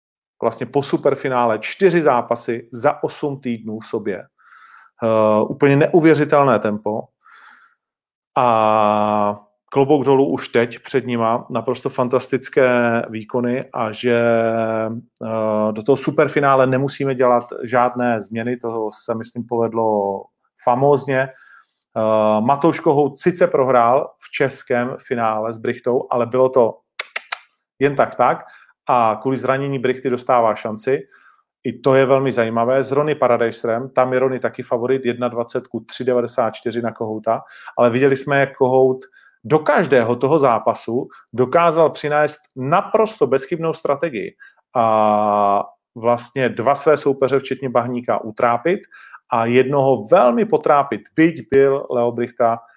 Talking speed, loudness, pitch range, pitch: 125 wpm, -18 LUFS, 115-135 Hz, 125 Hz